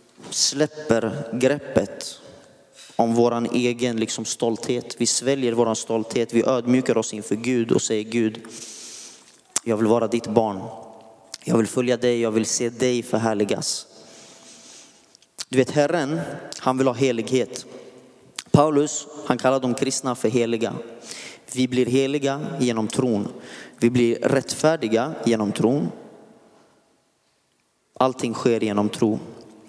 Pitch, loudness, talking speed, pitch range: 120 Hz, -22 LUFS, 125 wpm, 115-130 Hz